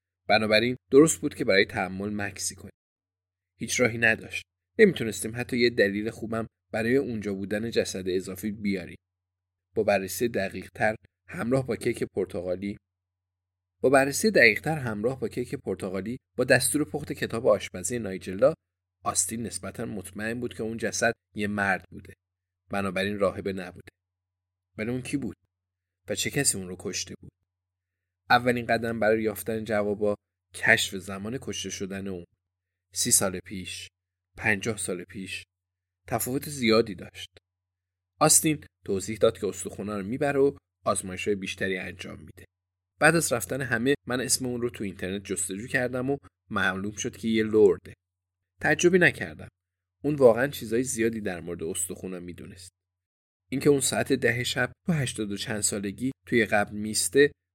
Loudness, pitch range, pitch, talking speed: -26 LUFS, 90-115 Hz, 100 Hz, 145 wpm